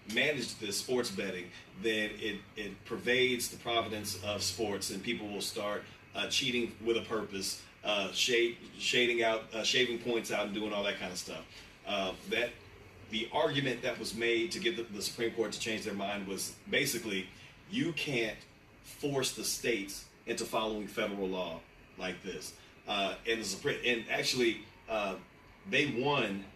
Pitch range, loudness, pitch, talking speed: 100-120 Hz, -34 LUFS, 110 Hz, 170 wpm